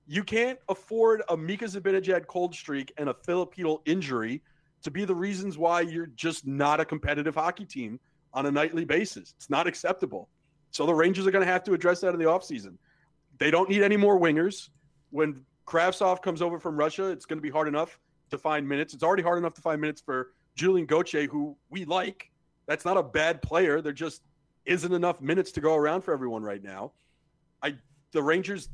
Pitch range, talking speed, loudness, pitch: 150-185 Hz, 200 wpm, -28 LUFS, 160 Hz